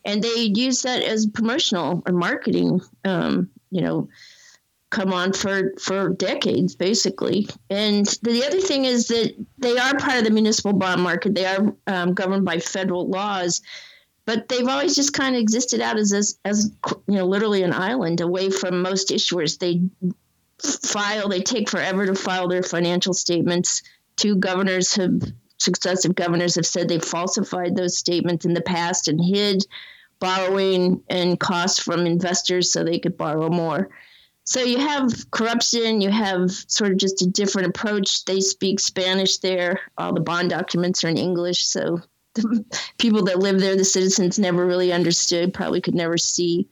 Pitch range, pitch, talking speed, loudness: 180-210 Hz, 190 Hz, 170 wpm, -21 LUFS